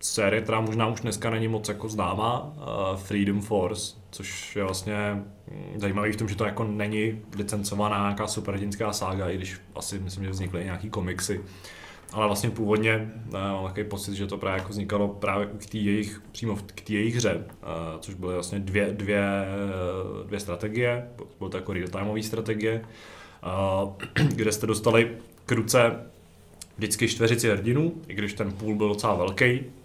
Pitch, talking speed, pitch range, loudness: 105 Hz, 165 wpm, 100-110 Hz, -28 LUFS